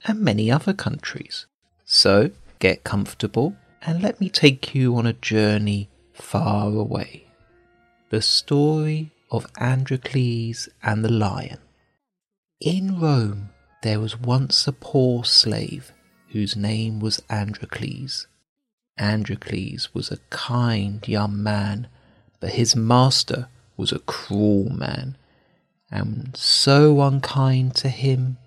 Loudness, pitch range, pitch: -21 LUFS, 105-140 Hz, 120 Hz